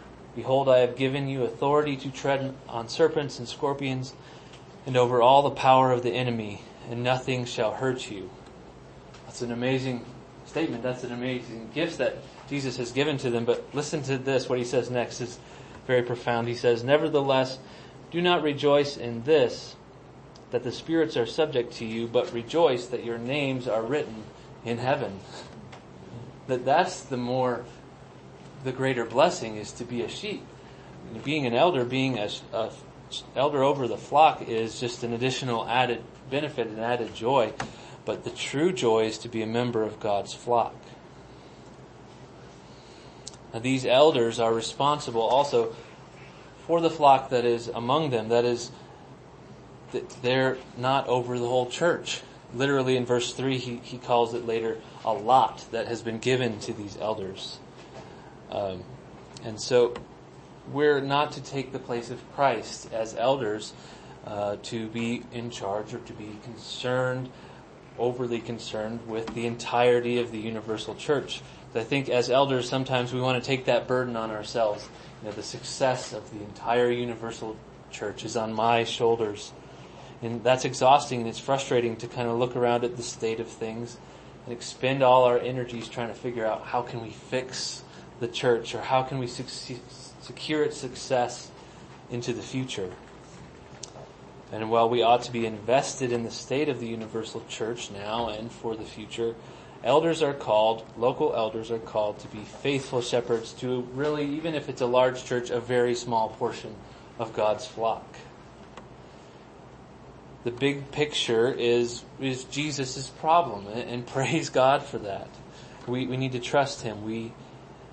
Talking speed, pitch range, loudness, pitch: 165 wpm, 115-130 Hz, -27 LUFS, 120 Hz